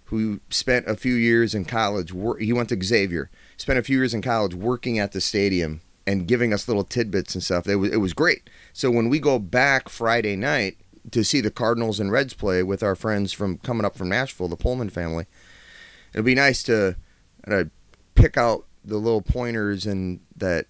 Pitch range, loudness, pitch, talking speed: 95-120 Hz, -23 LUFS, 105 Hz, 200 wpm